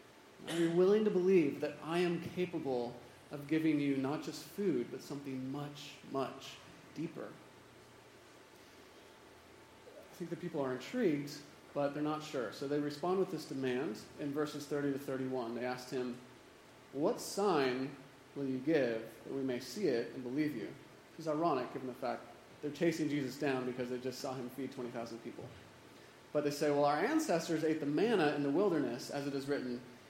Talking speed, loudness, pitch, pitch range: 180 wpm, -37 LUFS, 145 Hz, 130-155 Hz